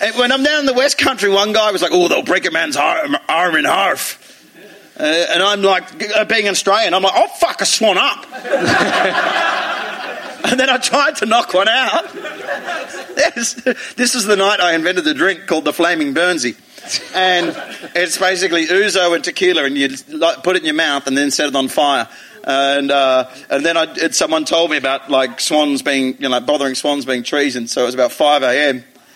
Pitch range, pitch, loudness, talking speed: 145-235 Hz, 180 Hz, -15 LUFS, 205 wpm